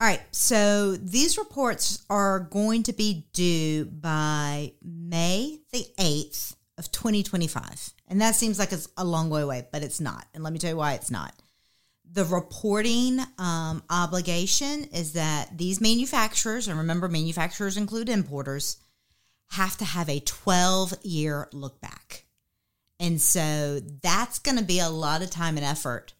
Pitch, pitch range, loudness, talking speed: 175 Hz, 155-205 Hz, -26 LUFS, 160 wpm